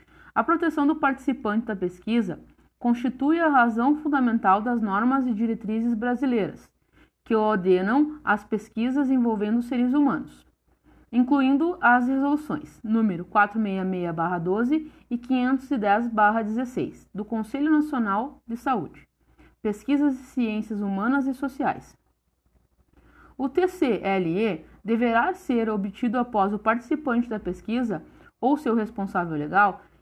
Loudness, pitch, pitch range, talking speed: -24 LUFS, 235 Hz, 210-270 Hz, 110 wpm